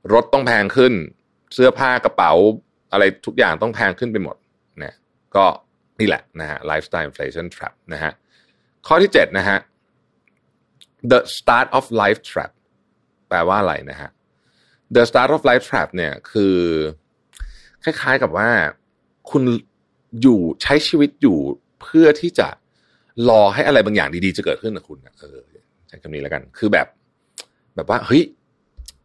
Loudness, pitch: -17 LUFS, 105 Hz